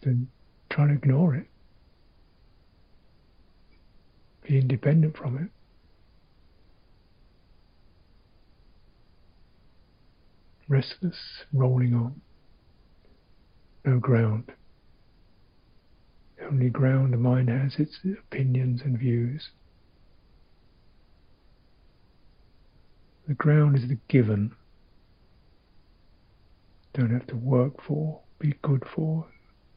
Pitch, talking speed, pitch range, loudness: 120 Hz, 75 wpm, 90-135 Hz, -26 LUFS